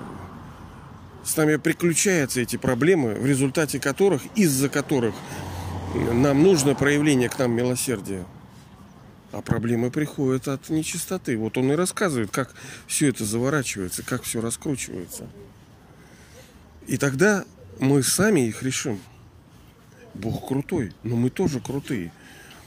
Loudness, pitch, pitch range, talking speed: -23 LUFS, 130 Hz, 115-145 Hz, 115 wpm